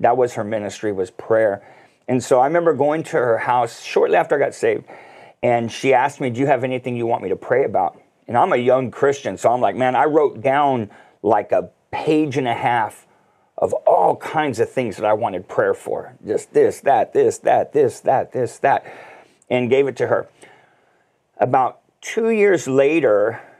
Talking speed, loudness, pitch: 200 wpm, -19 LUFS, 150 Hz